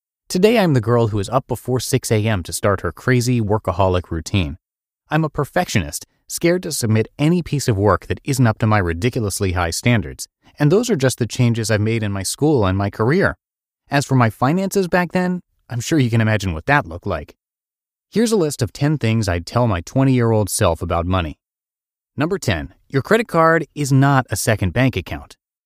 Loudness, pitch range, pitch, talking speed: -18 LUFS, 100-140 Hz, 120 Hz, 210 wpm